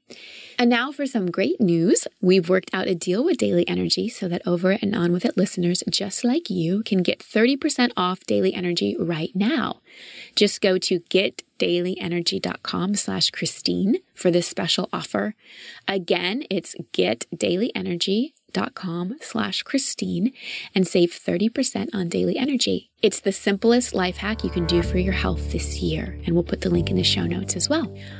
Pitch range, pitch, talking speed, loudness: 175-210 Hz, 185 Hz, 165 wpm, -23 LUFS